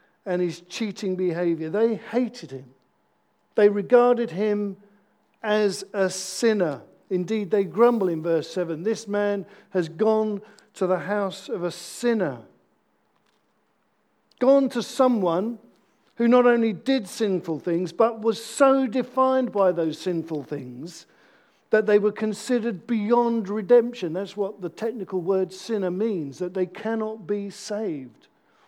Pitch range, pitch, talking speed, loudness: 180-225 Hz, 205 Hz, 135 wpm, -24 LUFS